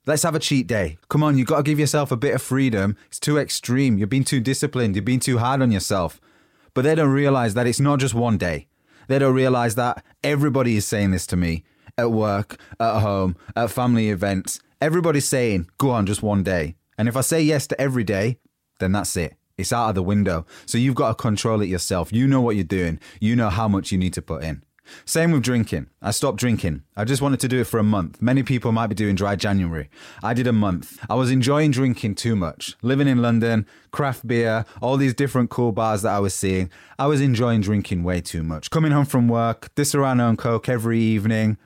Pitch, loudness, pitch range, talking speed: 115 Hz, -21 LUFS, 100-130 Hz, 235 wpm